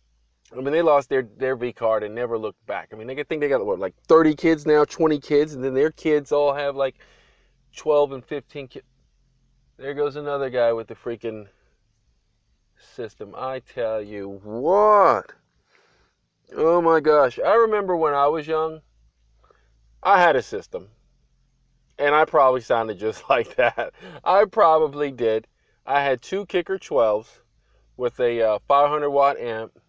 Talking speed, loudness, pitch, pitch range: 165 wpm, -21 LUFS, 140 Hz, 115-155 Hz